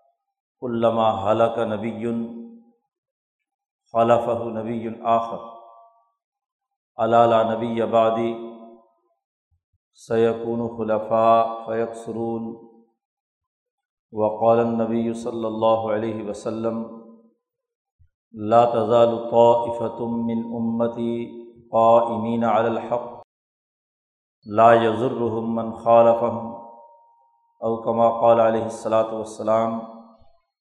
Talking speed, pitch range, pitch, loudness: 60 wpm, 115-120 Hz, 115 Hz, -21 LUFS